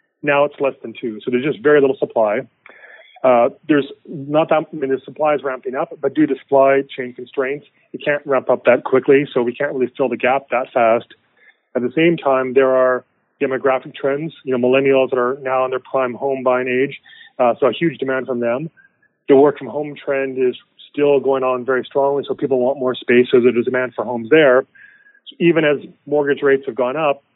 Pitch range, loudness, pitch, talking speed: 130-145 Hz, -17 LUFS, 135 Hz, 220 wpm